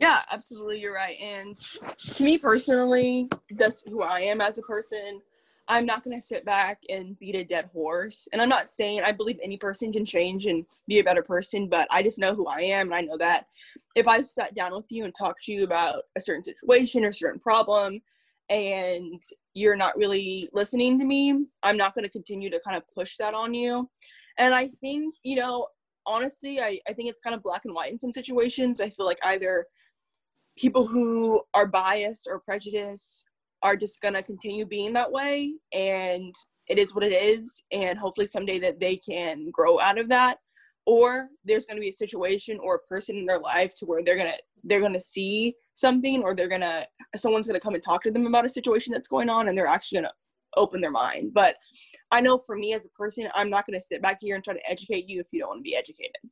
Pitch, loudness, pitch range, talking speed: 210 Hz, -26 LUFS, 195-245 Hz, 230 wpm